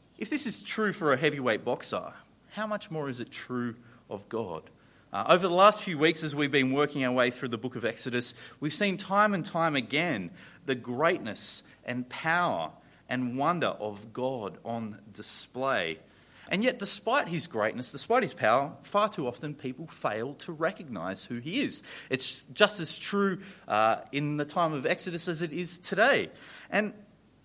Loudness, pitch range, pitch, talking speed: -29 LUFS, 125-175 Hz, 145 Hz, 180 wpm